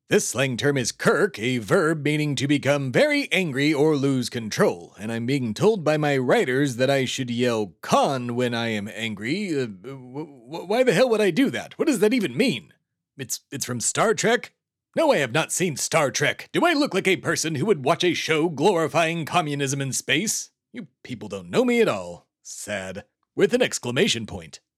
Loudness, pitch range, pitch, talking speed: -22 LUFS, 125-170 Hz, 145 Hz, 205 wpm